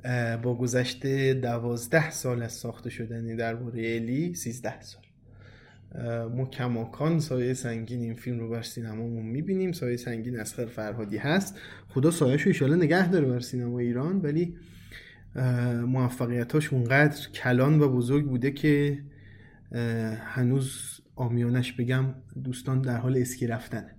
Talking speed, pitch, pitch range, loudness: 130 wpm, 125 Hz, 115-135 Hz, -28 LUFS